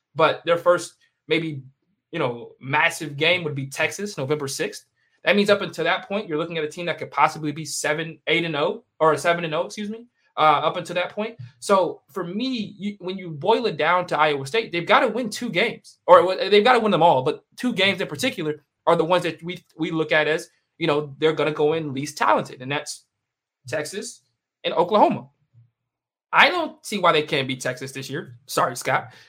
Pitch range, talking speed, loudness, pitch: 150-190 Hz, 220 wpm, -22 LUFS, 160 Hz